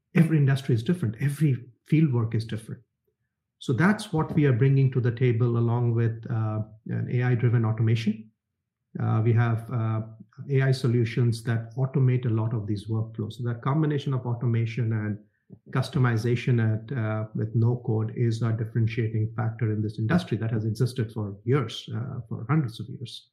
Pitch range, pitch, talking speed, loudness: 110-130 Hz, 120 Hz, 170 wpm, -26 LUFS